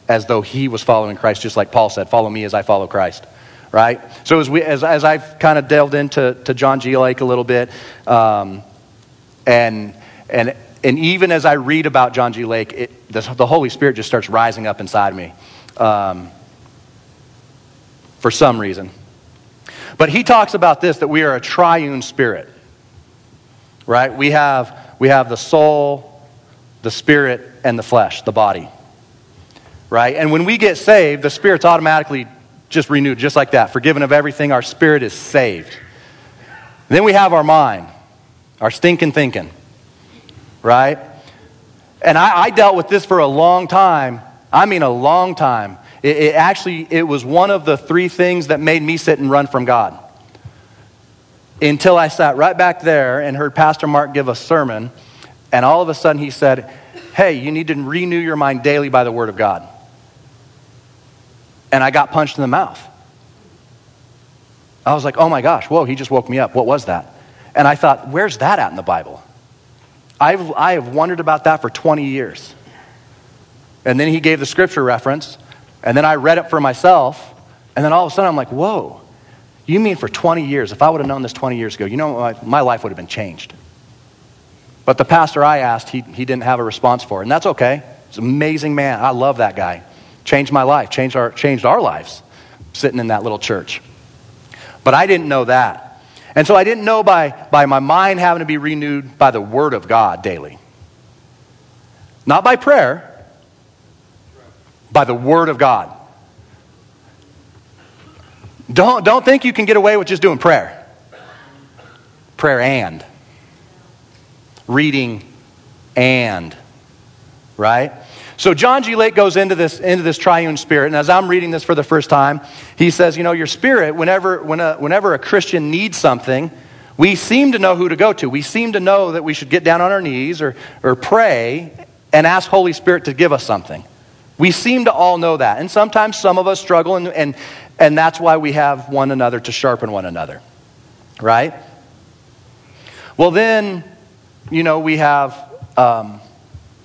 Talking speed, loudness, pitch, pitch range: 185 wpm, -14 LUFS, 140 Hz, 120-160 Hz